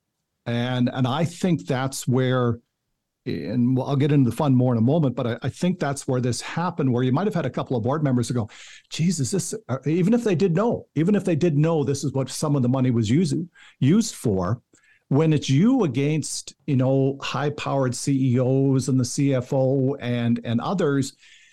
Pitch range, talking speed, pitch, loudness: 125-155 Hz, 205 wpm, 135 Hz, -23 LUFS